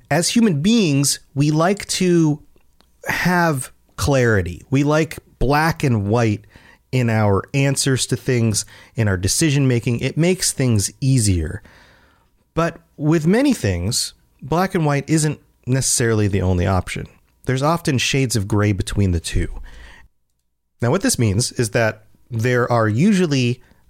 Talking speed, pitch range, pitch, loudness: 140 wpm, 105-150 Hz, 125 Hz, -18 LUFS